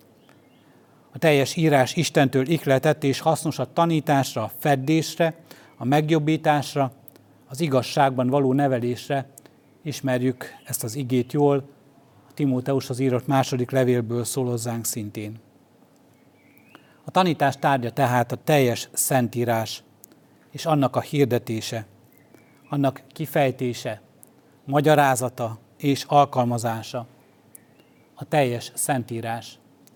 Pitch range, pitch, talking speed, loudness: 120-145 Hz, 135 Hz, 100 wpm, -23 LUFS